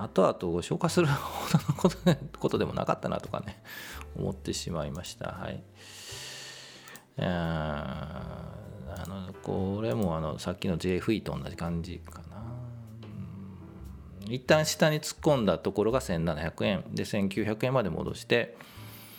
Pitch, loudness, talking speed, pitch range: 100 Hz, -30 LUFS, 230 characters per minute, 85-125 Hz